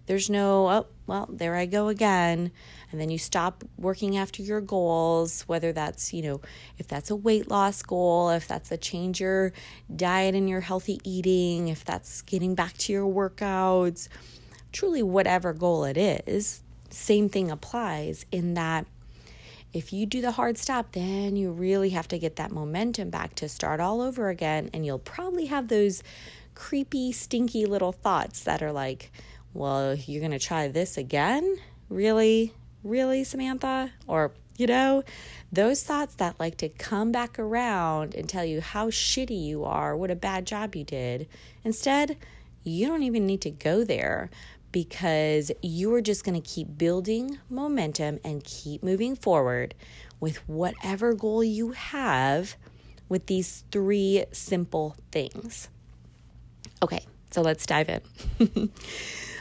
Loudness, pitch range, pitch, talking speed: -27 LUFS, 160-215 Hz, 185 Hz, 155 wpm